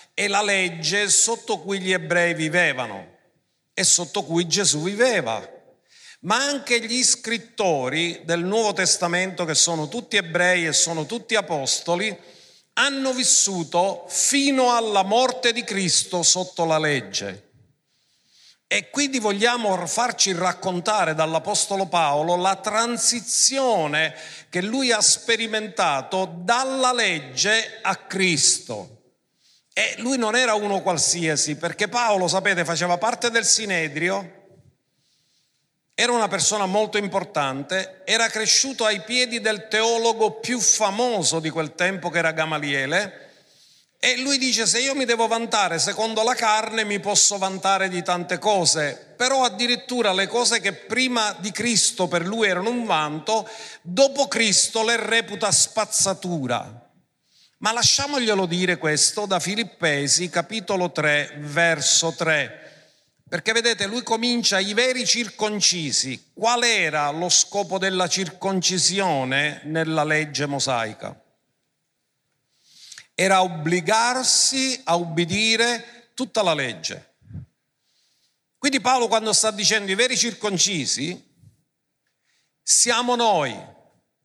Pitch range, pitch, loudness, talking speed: 170-230 Hz, 195 Hz, -20 LUFS, 120 wpm